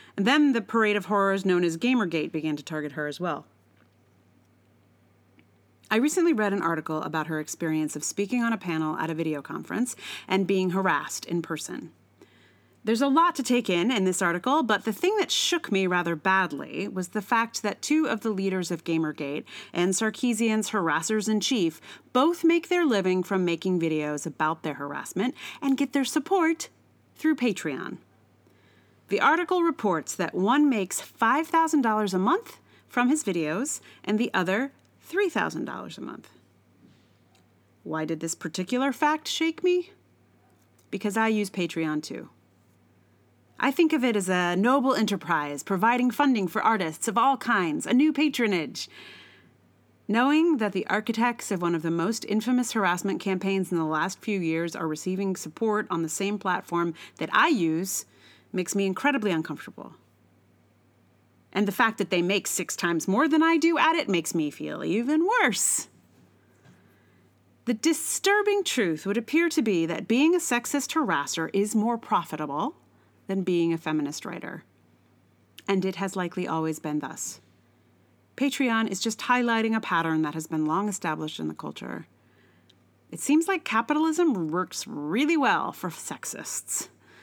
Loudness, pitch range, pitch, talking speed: -26 LUFS, 155-245 Hz, 190 Hz, 160 wpm